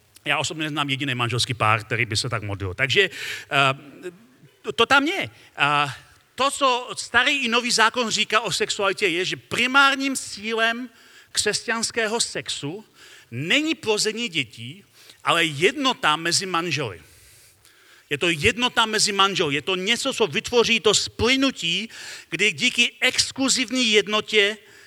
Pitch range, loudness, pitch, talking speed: 145-240 Hz, -21 LUFS, 215 Hz, 130 wpm